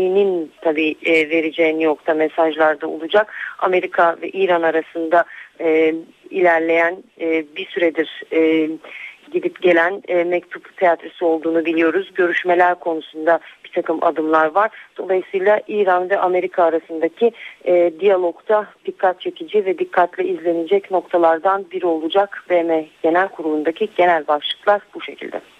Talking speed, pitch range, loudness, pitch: 120 wpm, 165-190 Hz, -18 LUFS, 175 Hz